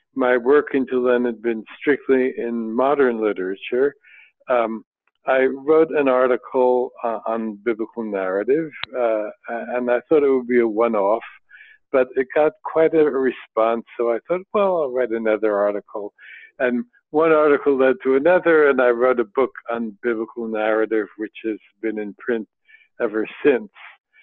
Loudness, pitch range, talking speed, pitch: -20 LUFS, 115-140 Hz, 160 wpm, 125 Hz